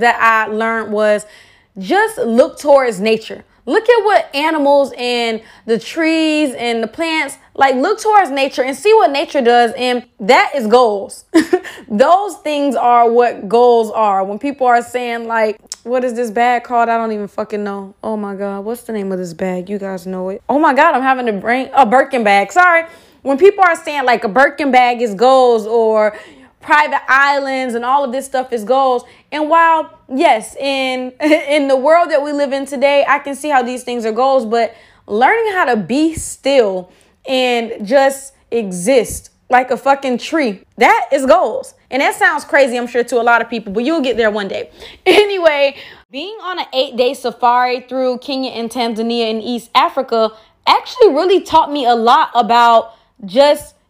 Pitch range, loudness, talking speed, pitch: 230-295 Hz, -14 LUFS, 190 wpm, 255 Hz